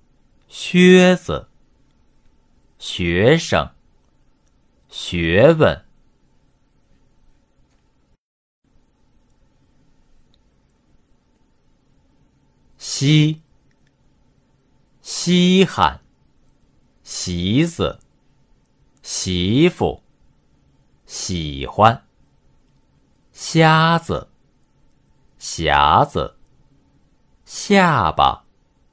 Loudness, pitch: -17 LUFS, 95 Hz